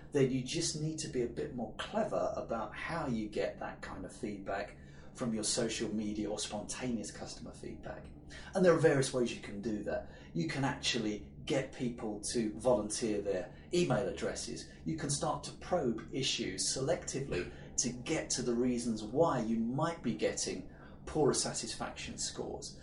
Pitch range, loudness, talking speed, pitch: 105-135 Hz, -35 LUFS, 170 wpm, 120 Hz